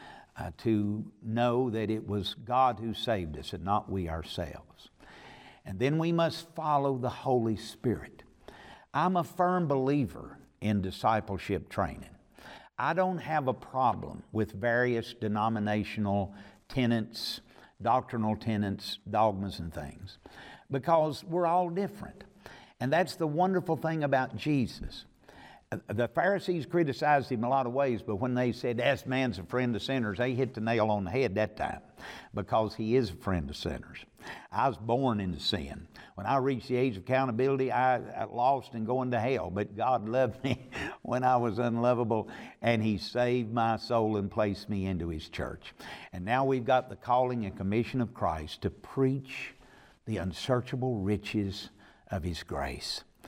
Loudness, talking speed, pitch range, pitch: -31 LUFS, 160 wpm, 105-130 Hz, 120 Hz